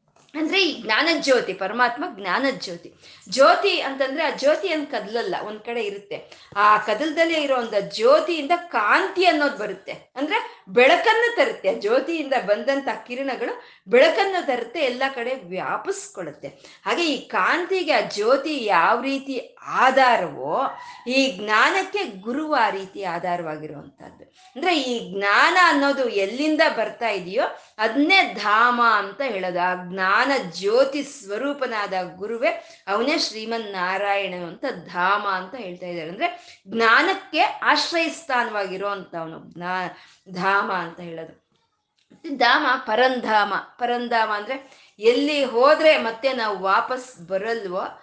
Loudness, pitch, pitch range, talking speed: -21 LUFS, 250 Hz, 200-310 Hz, 115 wpm